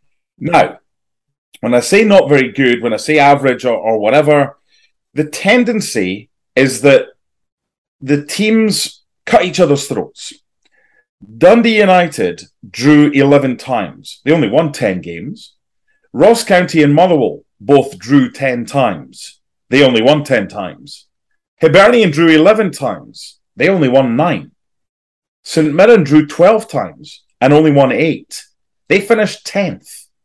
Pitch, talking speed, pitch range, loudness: 150 Hz, 135 wpm, 135-200 Hz, -11 LUFS